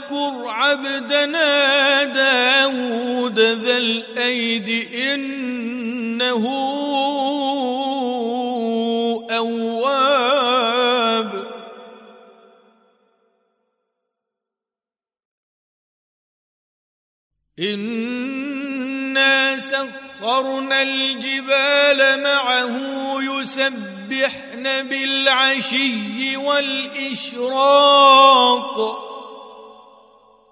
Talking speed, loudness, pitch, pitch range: 30 wpm, -17 LUFS, 265 Hz, 235-270 Hz